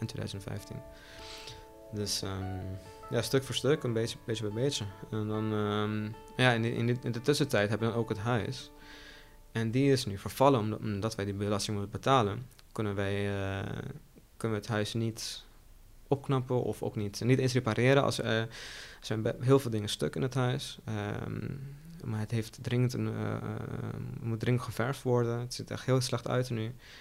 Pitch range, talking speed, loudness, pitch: 105-125 Hz, 190 wpm, -32 LUFS, 115 Hz